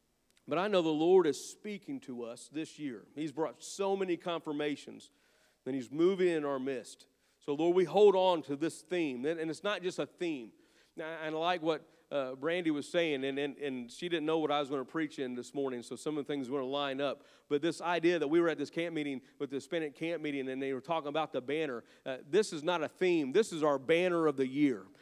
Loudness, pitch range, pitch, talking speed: -34 LUFS, 140-170 Hz, 155 Hz, 240 wpm